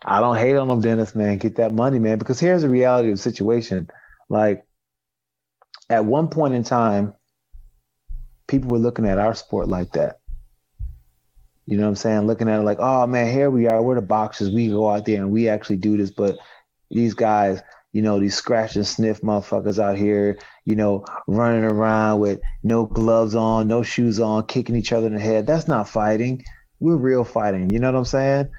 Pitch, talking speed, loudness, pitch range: 110 Hz, 205 wpm, -20 LUFS, 100-120 Hz